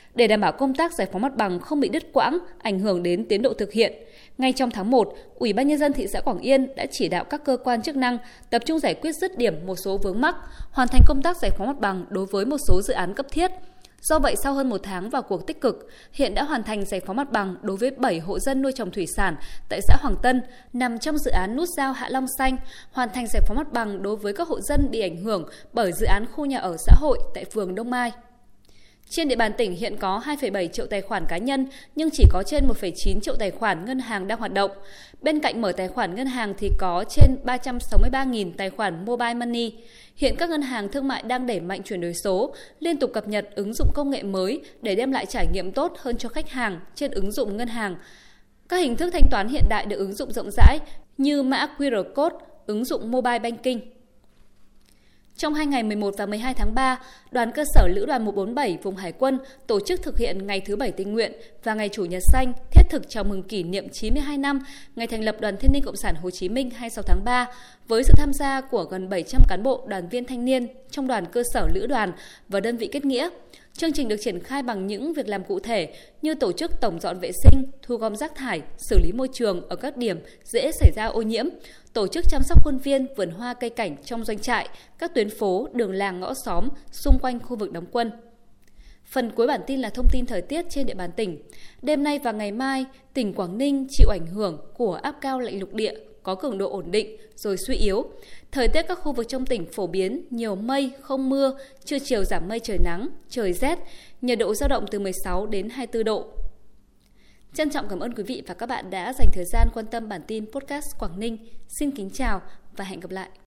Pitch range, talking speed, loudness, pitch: 200-275 Hz, 245 wpm, -25 LUFS, 240 Hz